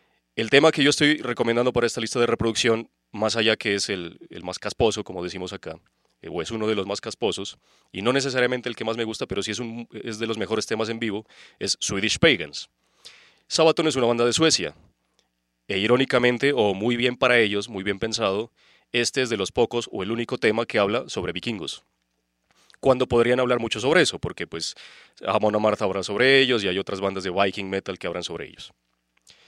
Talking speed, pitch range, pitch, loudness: 215 wpm, 100-125 Hz, 115 Hz, -23 LUFS